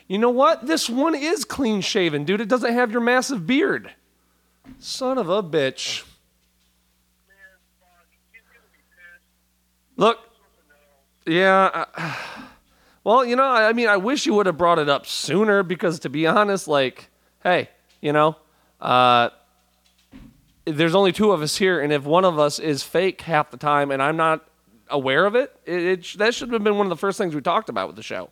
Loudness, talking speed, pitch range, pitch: -20 LUFS, 180 wpm, 145-225 Hz, 180 Hz